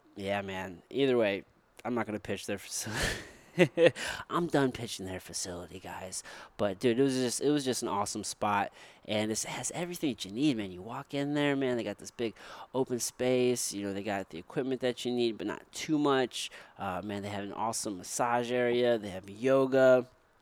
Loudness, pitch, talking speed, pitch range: -32 LUFS, 120 Hz, 205 wpm, 100-130 Hz